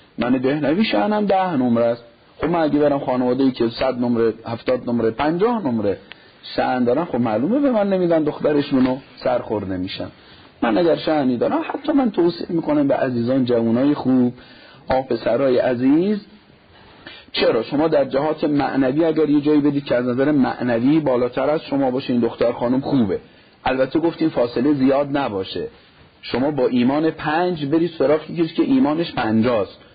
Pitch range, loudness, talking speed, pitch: 125-165 Hz, -19 LUFS, 160 wpm, 140 Hz